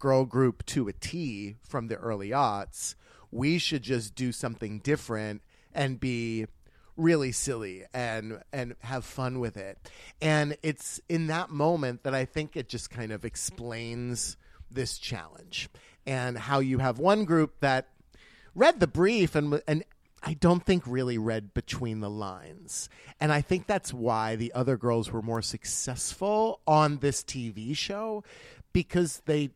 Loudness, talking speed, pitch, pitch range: -29 LUFS, 155 wpm, 130 Hz, 115-155 Hz